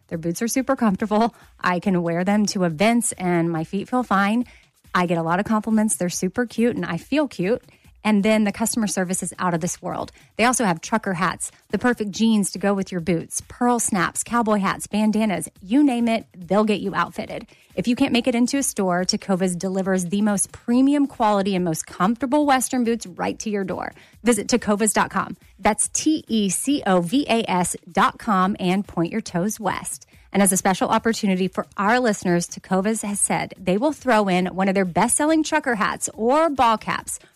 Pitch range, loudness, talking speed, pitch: 185-235 Hz, -21 LUFS, 195 wpm, 210 Hz